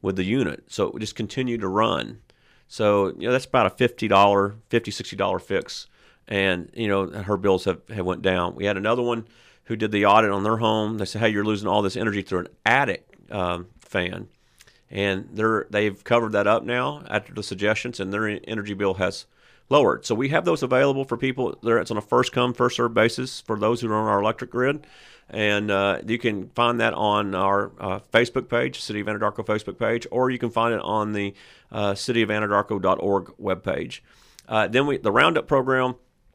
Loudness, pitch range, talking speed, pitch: -23 LUFS, 100-120 Hz, 205 wpm, 110 Hz